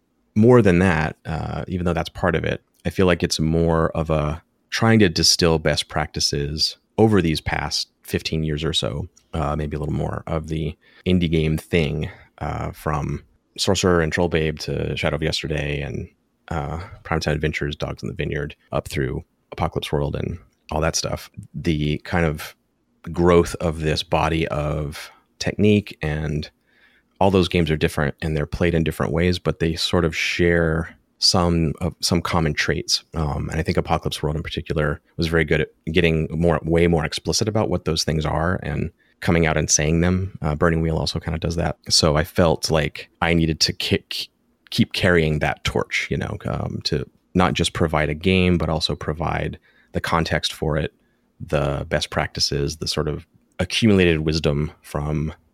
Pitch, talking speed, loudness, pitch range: 80 Hz, 185 wpm, -21 LUFS, 75-85 Hz